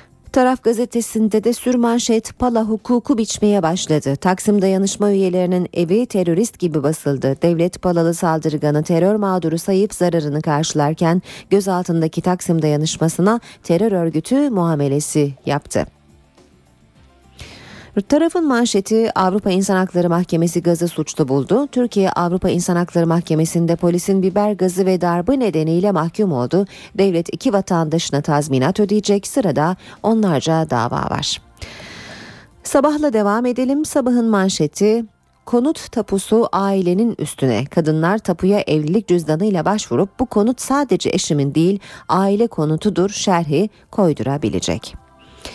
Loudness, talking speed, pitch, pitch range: -17 LUFS, 110 wpm, 185 Hz, 160-210 Hz